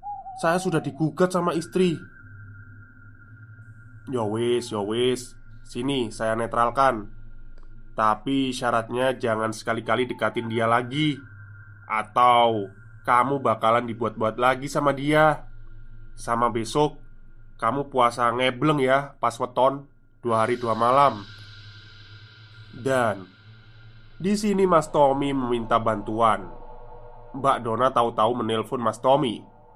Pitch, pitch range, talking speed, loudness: 120 Hz, 110-135 Hz, 100 wpm, -23 LUFS